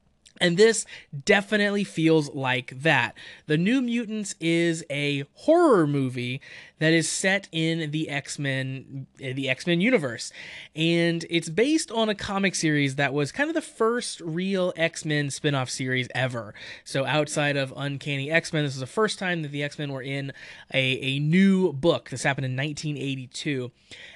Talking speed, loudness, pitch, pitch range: 155 wpm, -25 LUFS, 150 Hz, 135-180 Hz